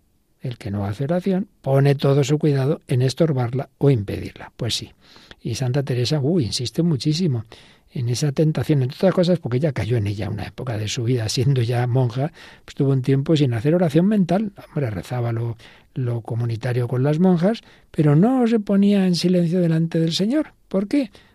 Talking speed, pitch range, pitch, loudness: 190 wpm, 125-175 Hz, 140 Hz, -21 LUFS